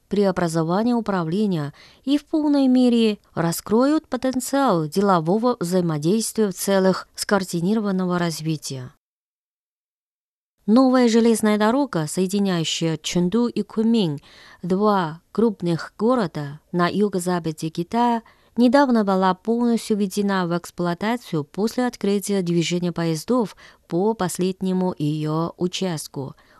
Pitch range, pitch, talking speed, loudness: 175-230 Hz, 195 Hz, 95 wpm, -21 LUFS